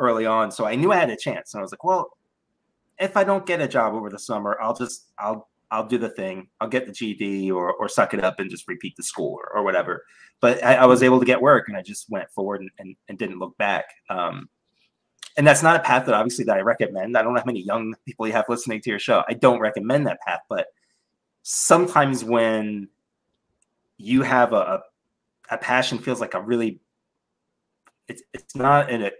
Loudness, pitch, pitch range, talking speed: -21 LUFS, 115 Hz, 105-130 Hz, 230 wpm